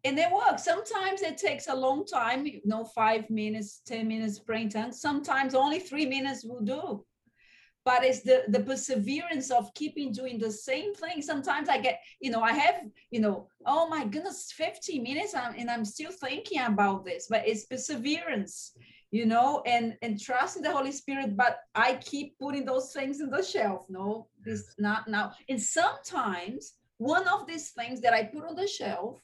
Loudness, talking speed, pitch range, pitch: -30 LUFS, 185 wpm, 225-305 Hz, 260 Hz